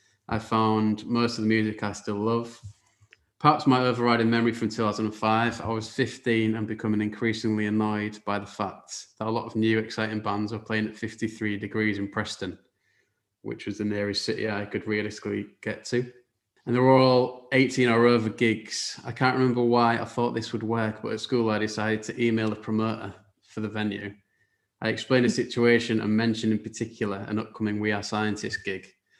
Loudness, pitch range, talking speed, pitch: -26 LUFS, 105-115 Hz, 190 wpm, 110 Hz